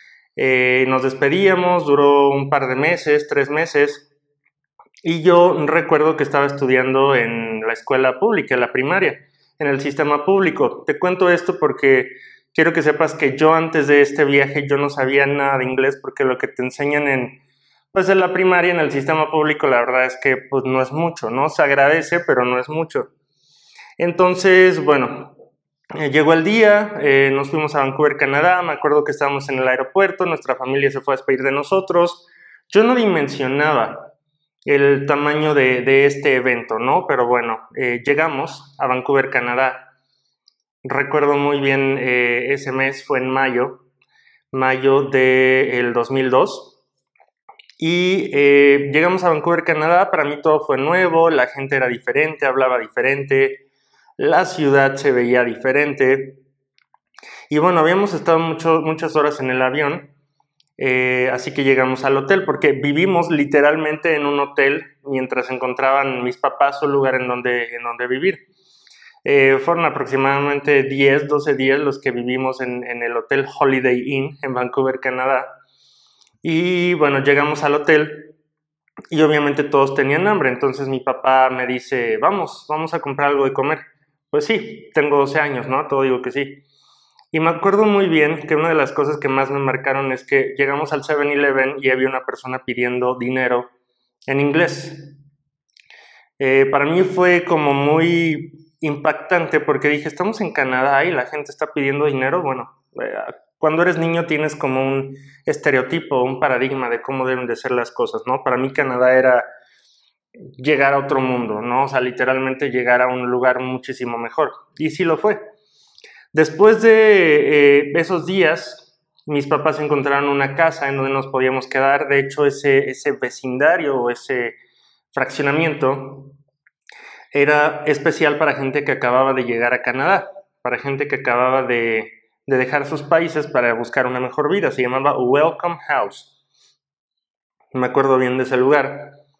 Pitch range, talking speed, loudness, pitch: 130-155 Hz, 165 wpm, -17 LUFS, 140 Hz